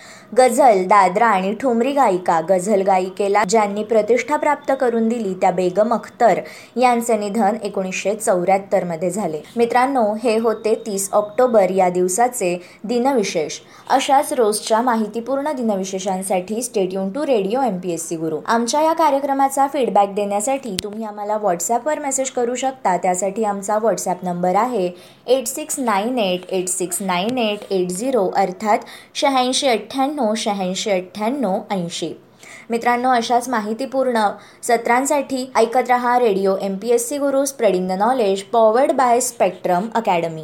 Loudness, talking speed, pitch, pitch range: -18 LUFS, 140 wpm, 220 Hz, 195-250 Hz